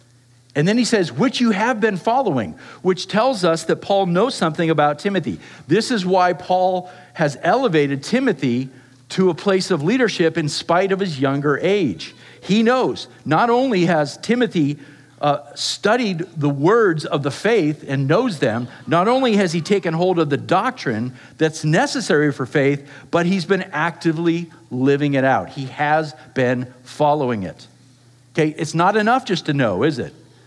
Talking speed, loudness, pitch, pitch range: 170 wpm, -19 LUFS, 165 Hz, 140-190 Hz